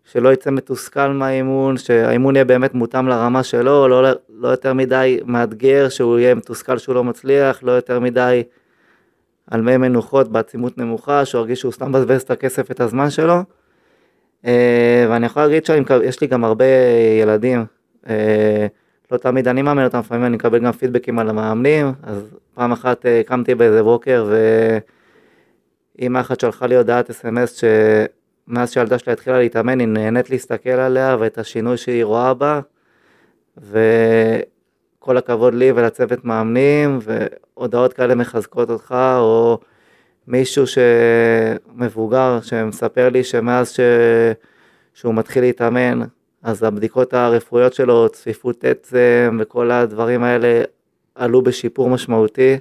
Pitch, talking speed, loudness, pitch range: 125 Hz, 135 wpm, -16 LUFS, 115-130 Hz